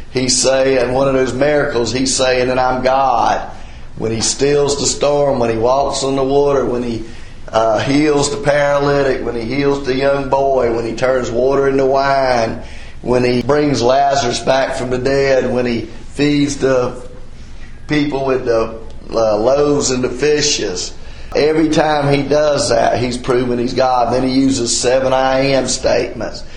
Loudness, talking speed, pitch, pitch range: -15 LUFS, 170 wpm, 130 Hz, 125-140 Hz